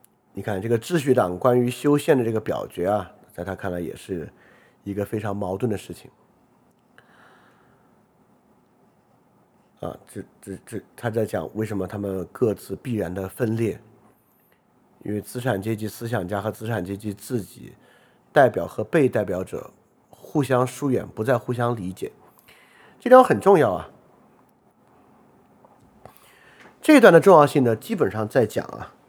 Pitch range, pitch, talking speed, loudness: 100-125 Hz, 110 Hz, 215 characters per minute, -22 LUFS